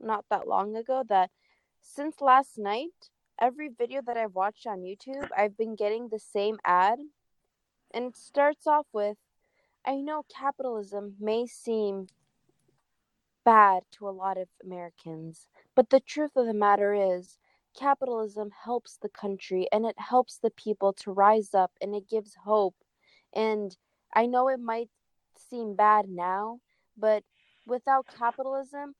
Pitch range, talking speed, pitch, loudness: 200-255 Hz, 145 wpm, 220 Hz, -28 LUFS